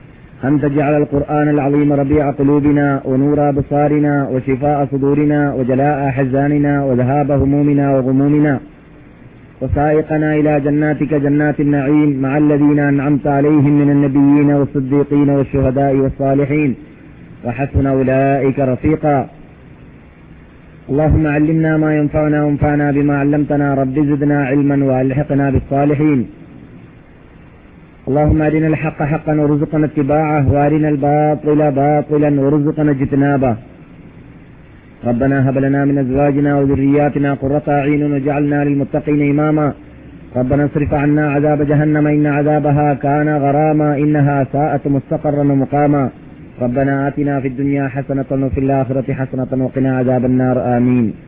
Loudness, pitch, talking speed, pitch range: -14 LUFS, 145 Hz, 105 wpm, 140-150 Hz